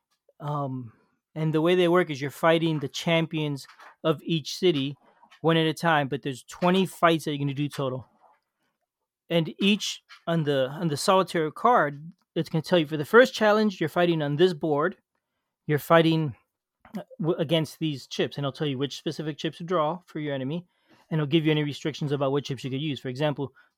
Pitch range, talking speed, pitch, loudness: 145-170 Hz, 205 wpm, 160 Hz, -26 LUFS